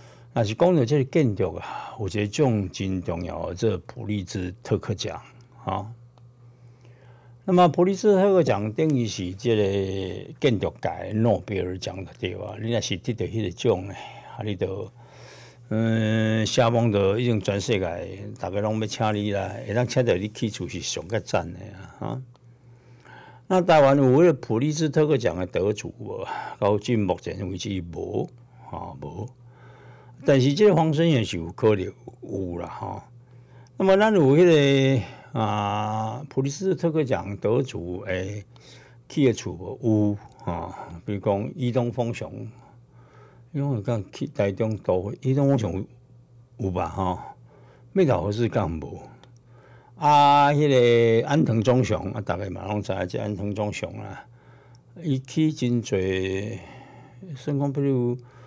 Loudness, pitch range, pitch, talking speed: -24 LUFS, 100-130 Hz, 115 Hz, 215 characters per minute